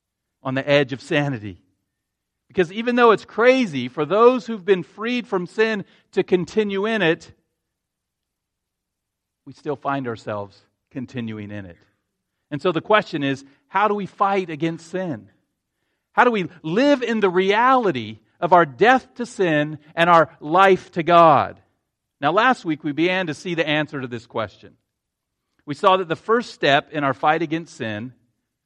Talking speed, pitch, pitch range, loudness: 165 wpm, 160 Hz, 135-195 Hz, -20 LUFS